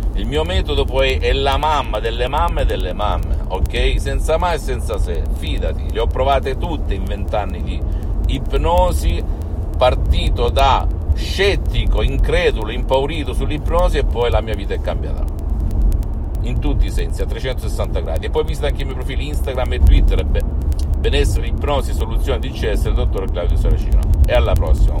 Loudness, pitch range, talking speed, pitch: -19 LUFS, 75-85 Hz, 165 wpm, 80 Hz